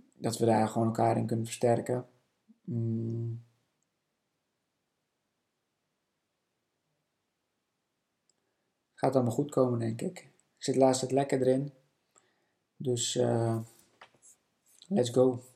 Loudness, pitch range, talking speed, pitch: -30 LUFS, 115-130 Hz, 95 wpm, 120 Hz